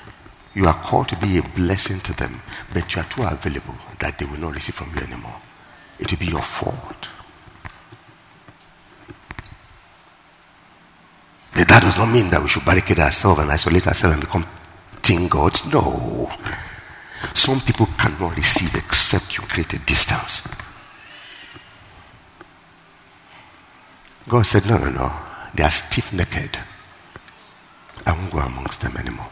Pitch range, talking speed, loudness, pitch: 80-105 Hz, 135 wpm, -16 LUFS, 90 Hz